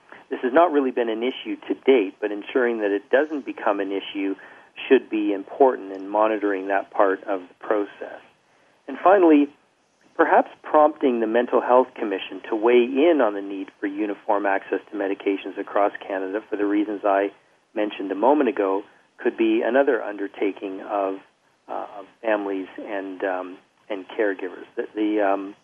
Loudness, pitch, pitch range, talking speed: -22 LUFS, 105 Hz, 100-130 Hz, 170 wpm